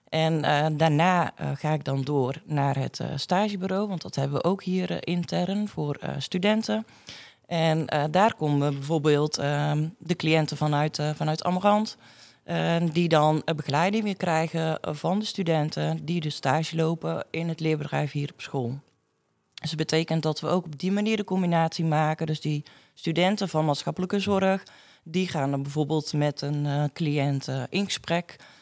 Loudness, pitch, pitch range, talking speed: -26 LUFS, 160 Hz, 145-180 Hz, 175 wpm